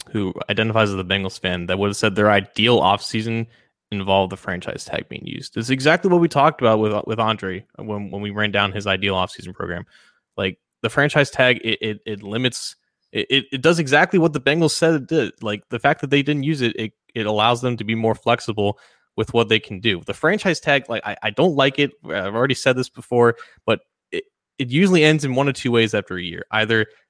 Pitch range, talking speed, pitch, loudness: 105-140 Hz, 235 wpm, 115 Hz, -20 LUFS